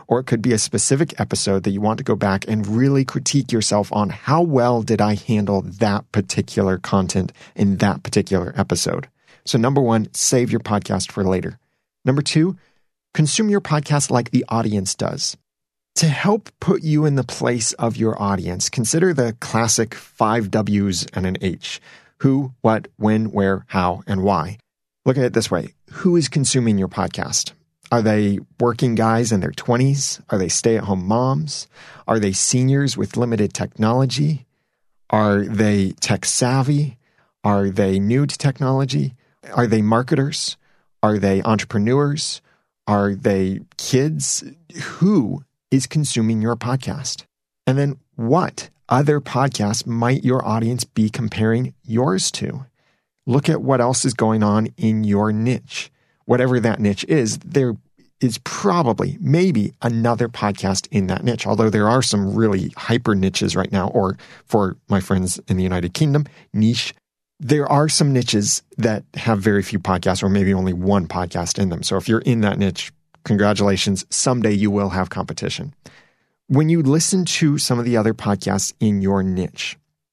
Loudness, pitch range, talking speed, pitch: -19 LUFS, 100-135 Hz, 165 wpm, 115 Hz